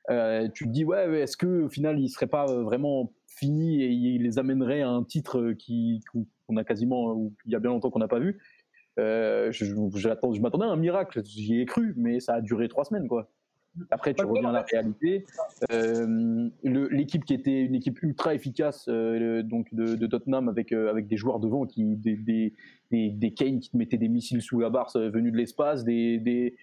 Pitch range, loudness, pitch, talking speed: 115-140 Hz, -28 LUFS, 120 Hz, 230 wpm